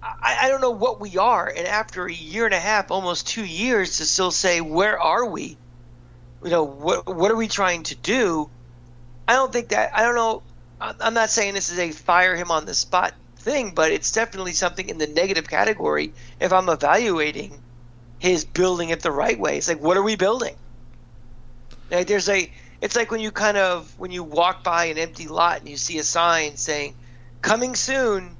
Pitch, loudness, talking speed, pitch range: 175 Hz, -21 LUFS, 205 wpm, 145-205 Hz